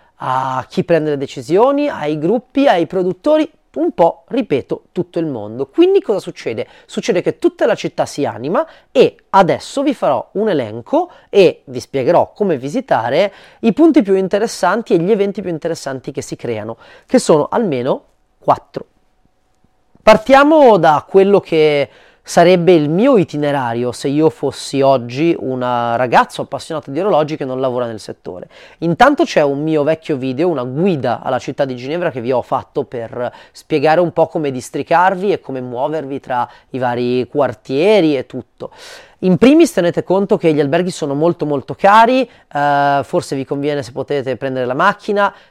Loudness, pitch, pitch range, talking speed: -15 LUFS, 165 Hz, 140-210 Hz, 165 wpm